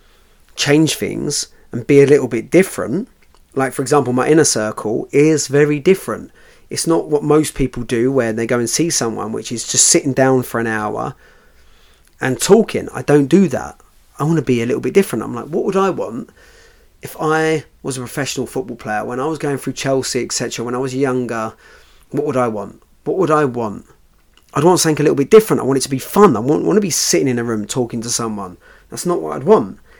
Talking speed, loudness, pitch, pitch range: 230 wpm, -16 LUFS, 135 Hz, 115-150 Hz